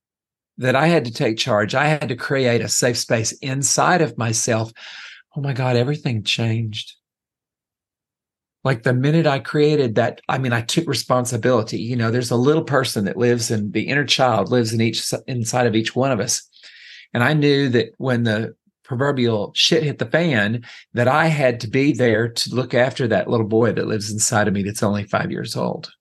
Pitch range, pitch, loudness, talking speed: 115-140 Hz, 125 Hz, -19 LUFS, 200 wpm